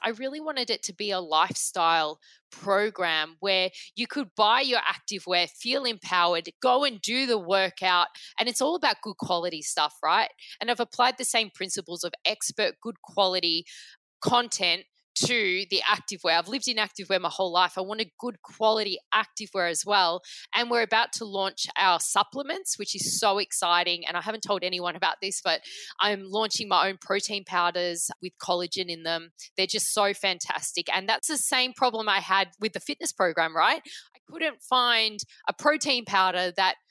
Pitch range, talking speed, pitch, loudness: 180-235 Hz, 185 wpm, 200 Hz, -26 LUFS